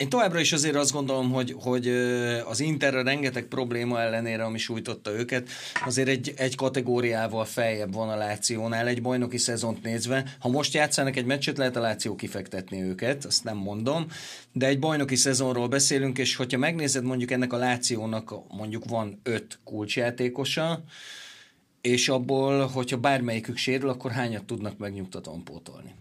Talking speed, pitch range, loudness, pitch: 155 wpm, 115-135 Hz, -27 LUFS, 125 Hz